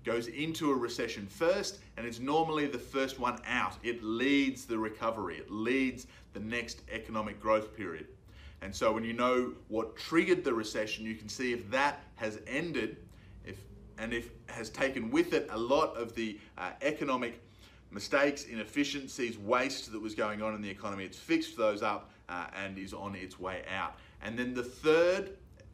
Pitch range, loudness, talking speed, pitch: 105-130 Hz, -34 LUFS, 180 wpm, 115 Hz